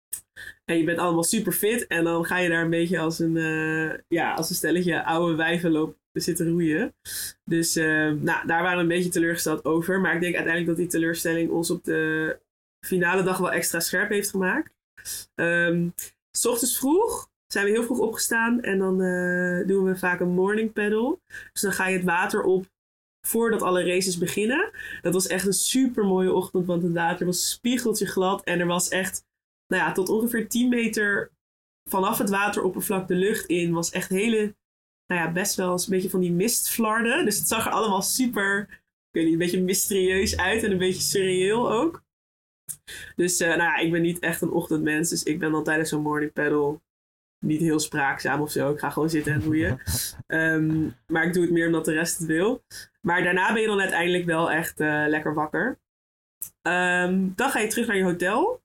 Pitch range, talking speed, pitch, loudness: 165-195 Hz, 205 wpm, 180 Hz, -24 LUFS